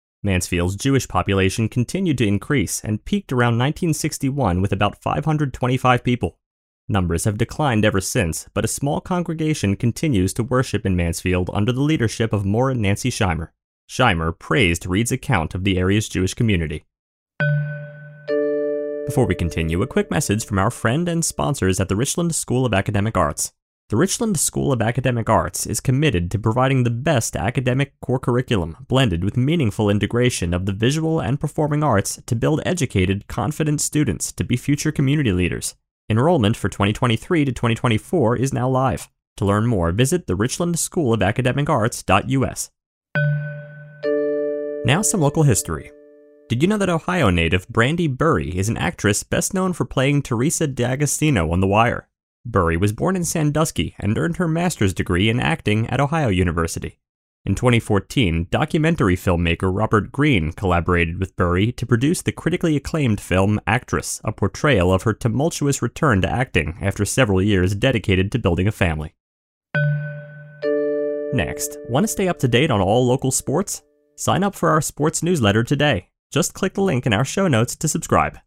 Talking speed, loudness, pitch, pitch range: 165 wpm, -20 LUFS, 125 Hz, 100-150 Hz